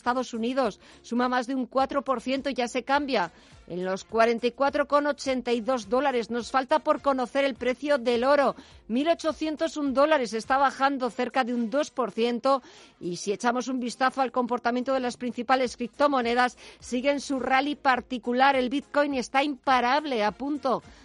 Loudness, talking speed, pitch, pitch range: -26 LUFS, 150 wpm, 260 Hz, 245-275 Hz